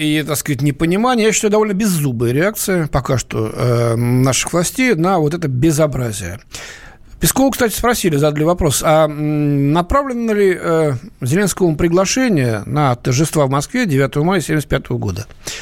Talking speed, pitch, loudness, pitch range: 135 wpm, 155 Hz, -16 LUFS, 135-190 Hz